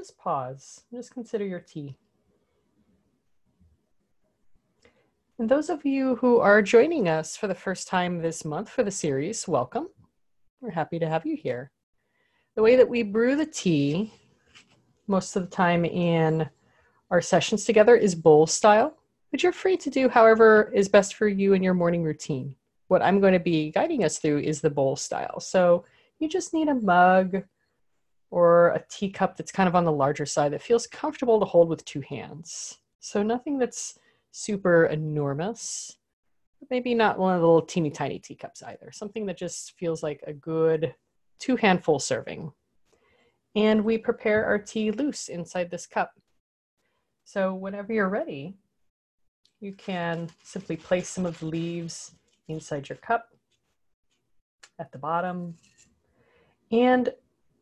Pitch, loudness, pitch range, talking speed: 190 Hz, -24 LUFS, 165-230 Hz, 160 wpm